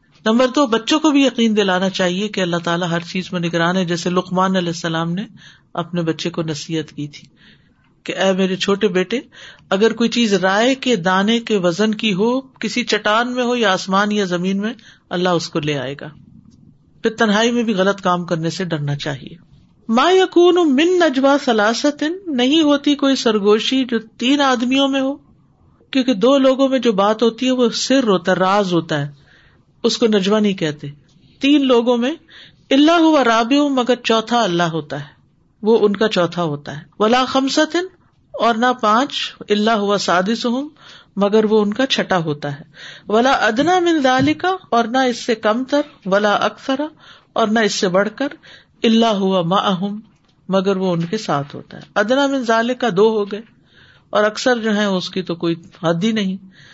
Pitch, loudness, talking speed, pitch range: 215 Hz, -17 LUFS, 185 wpm, 180-255 Hz